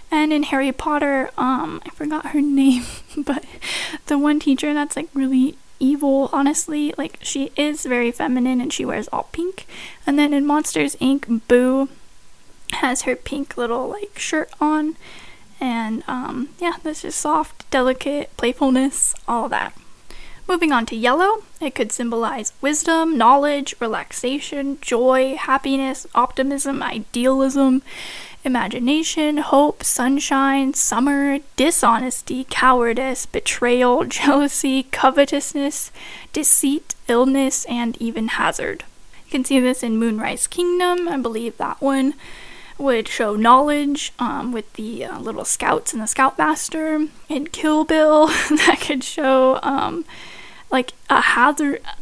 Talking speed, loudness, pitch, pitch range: 130 wpm, -19 LUFS, 275 Hz, 255-300 Hz